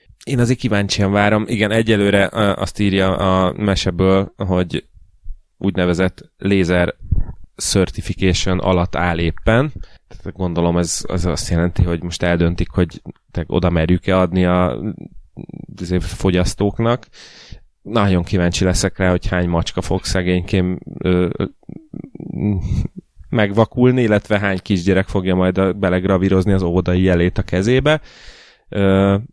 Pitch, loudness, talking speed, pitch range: 95 Hz, -17 LUFS, 115 wpm, 90-100 Hz